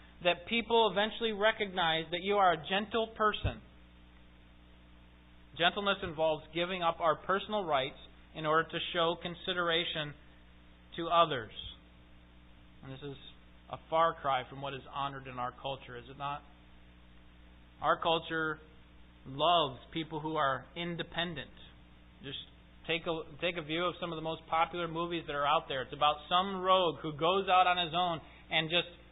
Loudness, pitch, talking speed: -32 LUFS, 160 Hz, 155 wpm